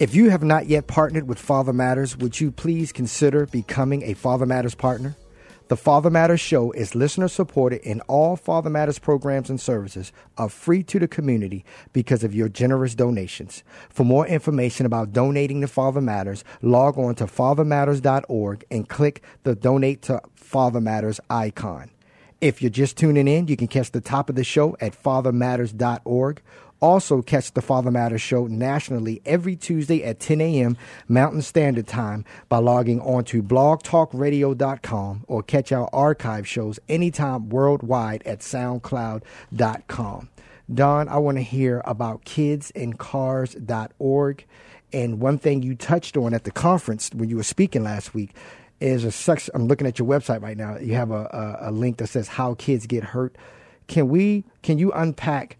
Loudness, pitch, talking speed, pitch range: -22 LUFS, 130 Hz, 165 wpm, 120-145 Hz